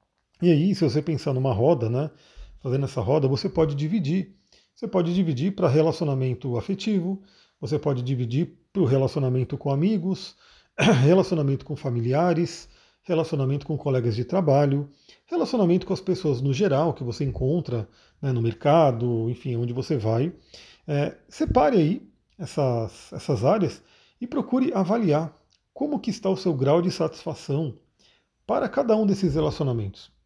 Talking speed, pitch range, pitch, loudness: 145 wpm, 130-175 Hz, 150 Hz, -24 LUFS